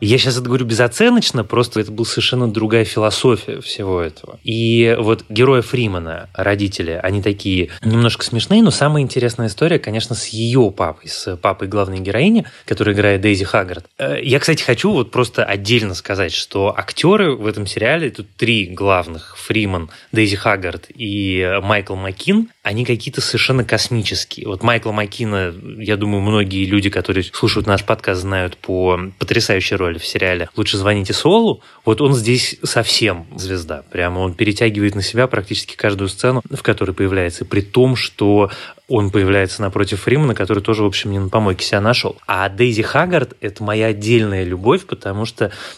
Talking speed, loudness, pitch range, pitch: 165 wpm, -16 LUFS, 100-120 Hz, 110 Hz